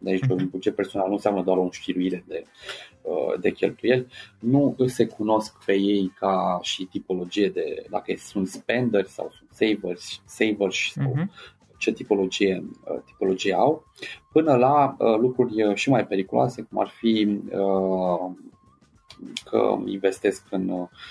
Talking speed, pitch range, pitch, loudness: 120 wpm, 95-125 Hz, 100 Hz, -24 LUFS